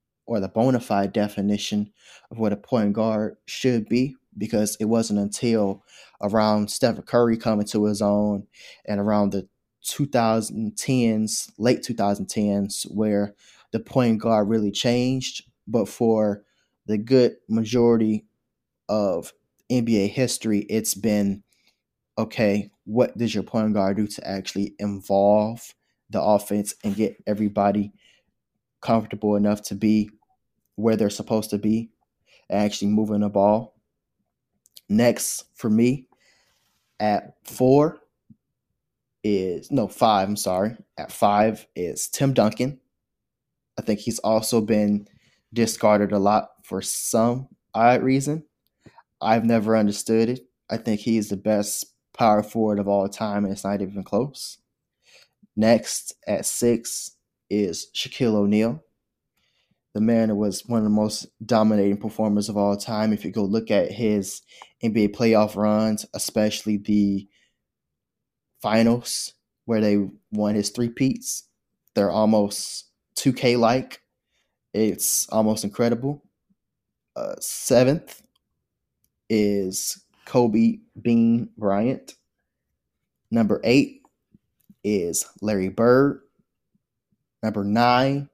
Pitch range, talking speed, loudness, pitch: 105-115 Hz, 120 wpm, -23 LUFS, 110 Hz